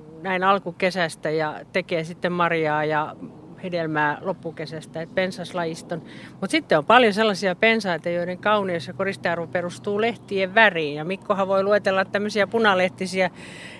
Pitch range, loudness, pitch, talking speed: 165-195 Hz, -22 LUFS, 185 Hz, 130 wpm